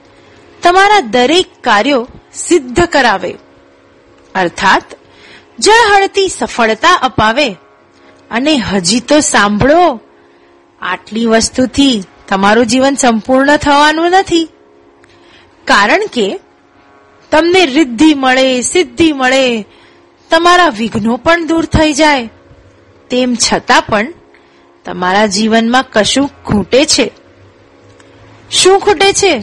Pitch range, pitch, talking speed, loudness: 215-330 Hz, 260 Hz, 90 wpm, -10 LUFS